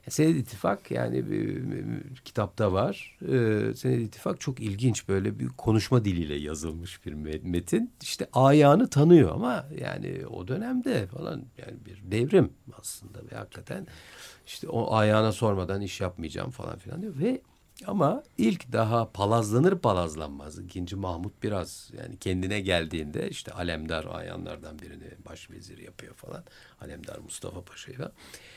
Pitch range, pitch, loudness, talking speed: 90-125 Hz, 105 Hz, -27 LUFS, 140 wpm